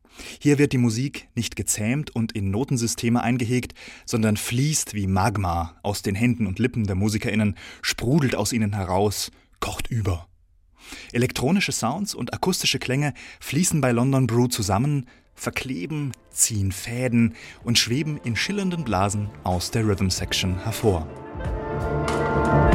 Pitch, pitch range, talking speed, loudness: 115 Hz, 100-125 Hz, 130 wpm, -24 LUFS